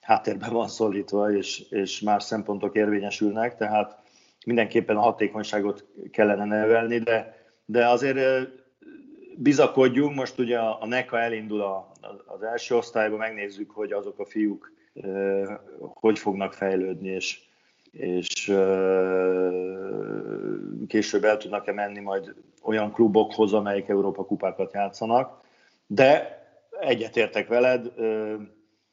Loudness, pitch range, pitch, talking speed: -25 LUFS, 100-120 Hz, 110 Hz, 105 wpm